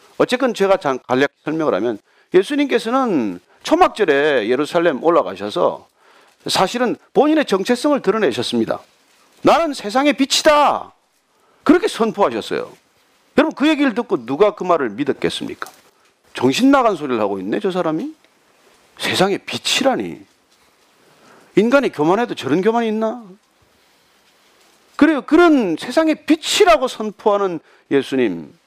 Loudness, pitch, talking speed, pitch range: -17 LUFS, 260 Hz, 295 characters per minute, 195-310 Hz